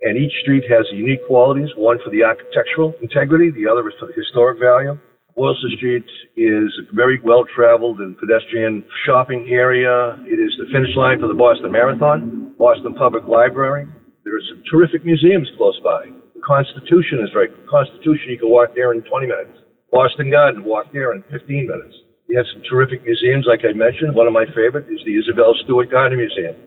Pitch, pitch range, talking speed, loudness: 130 Hz, 120-160 Hz, 195 wpm, -16 LUFS